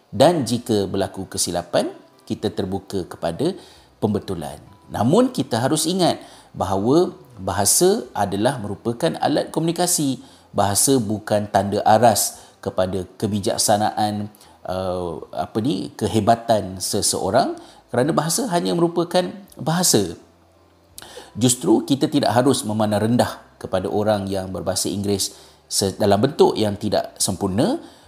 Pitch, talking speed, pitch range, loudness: 105 Hz, 105 wpm, 100-140 Hz, -20 LUFS